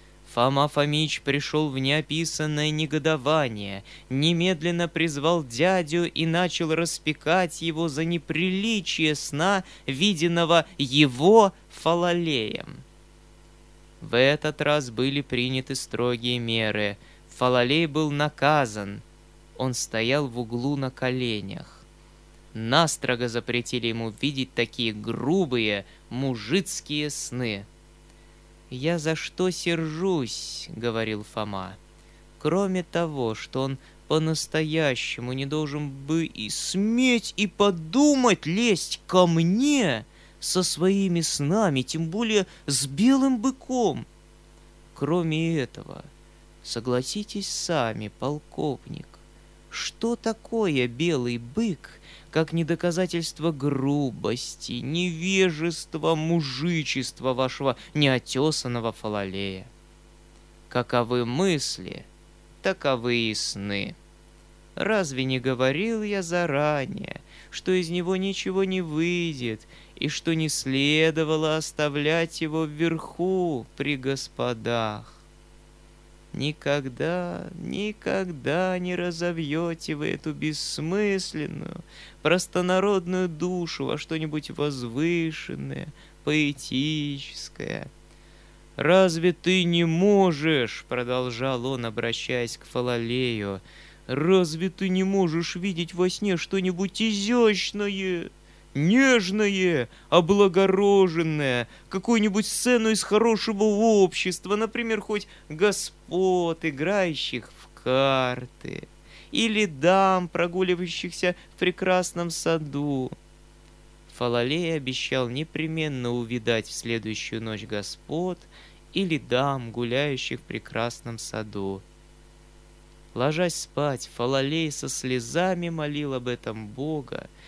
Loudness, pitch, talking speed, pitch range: -25 LUFS, 155 Hz, 90 wpm, 130-180 Hz